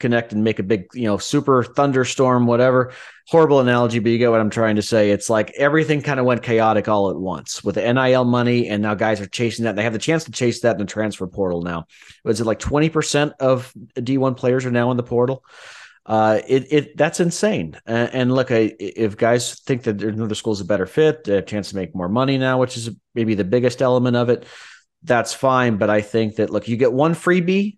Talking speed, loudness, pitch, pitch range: 240 wpm, -19 LUFS, 120 Hz, 110-130 Hz